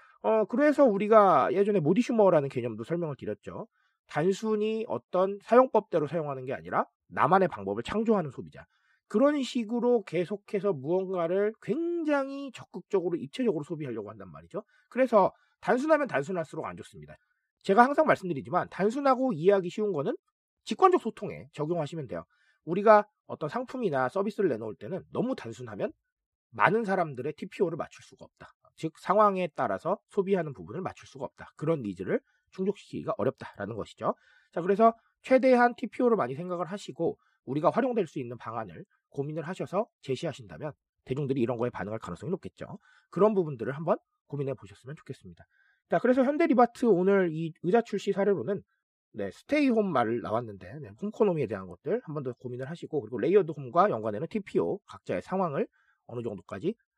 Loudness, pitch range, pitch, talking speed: -28 LUFS, 150-230 Hz, 195 Hz, 400 characters per minute